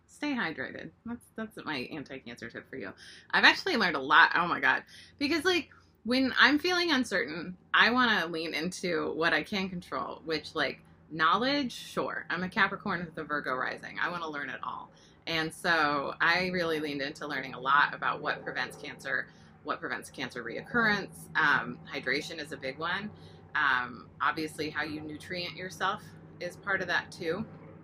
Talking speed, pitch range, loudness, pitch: 180 wpm, 150-210 Hz, -29 LUFS, 170 Hz